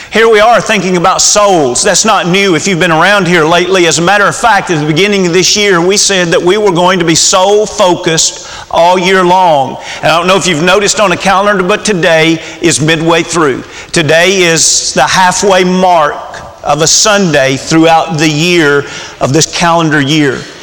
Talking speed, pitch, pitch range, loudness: 200 wpm, 180 Hz, 165-195 Hz, -7 LUFS